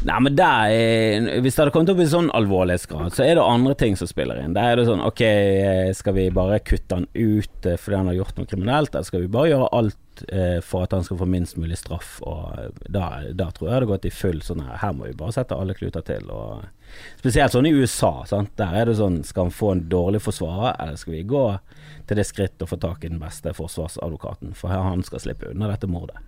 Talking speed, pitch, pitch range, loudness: 245 wpm, 95 Hz, 90-115 Hz, -22 LUFS